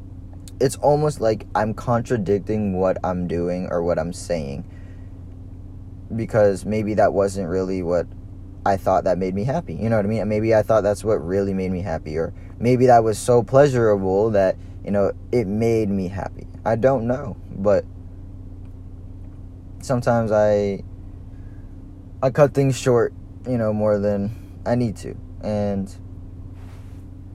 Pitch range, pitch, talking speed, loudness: 90-110 Hz, 95 Hz, 150 wpm, -21 LUFS